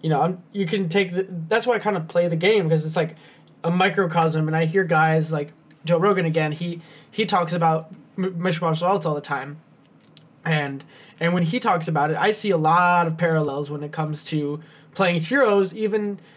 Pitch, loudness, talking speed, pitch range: 170 Hz, -22 LUFS, 205 wpm, 155-190 Hz